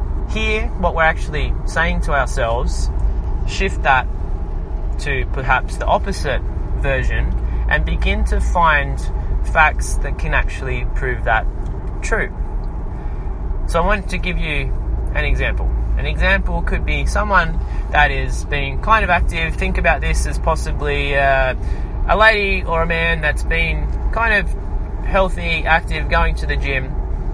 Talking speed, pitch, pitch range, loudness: 145 wpm, 80 Hz, 70-110 Hz, -19 LUFS